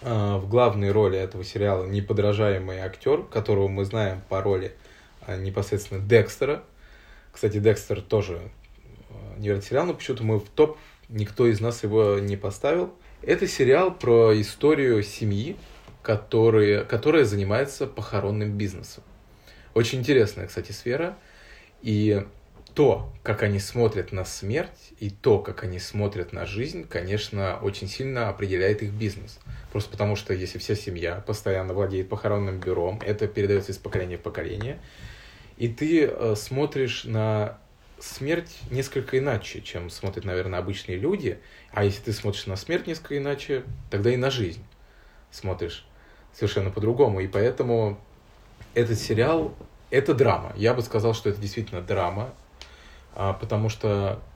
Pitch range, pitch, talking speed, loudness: 100-115 Hz, 105 Hz, 140 wpm, -25 LUFS